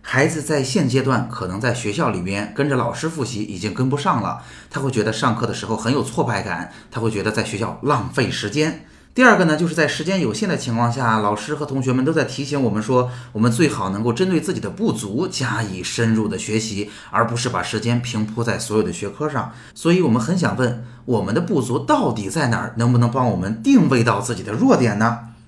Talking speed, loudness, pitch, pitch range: 340 characters per minute, -20 LUFS, 120 Hz, 110-145 Hz